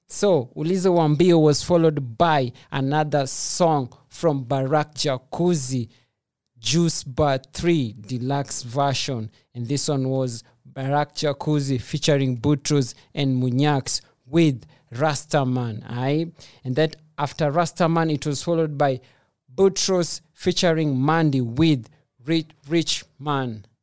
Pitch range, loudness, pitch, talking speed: 130-160 Hz, -22 LUFS, 145 Hz, 110 wpm